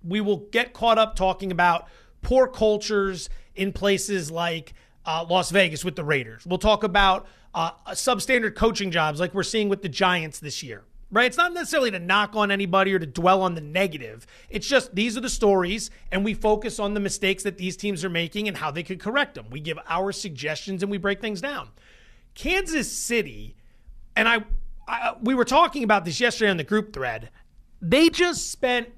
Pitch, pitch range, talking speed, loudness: 200 Hz, 180-225 Hz, 200 wpm, -23 LUFS